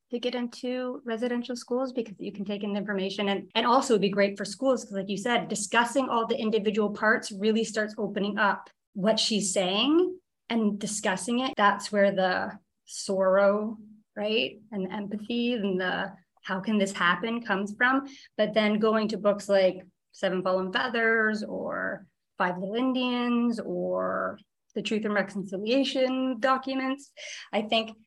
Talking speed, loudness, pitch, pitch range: 160 wpm, -27 LUFS, 215 Hz, 200-240 Hz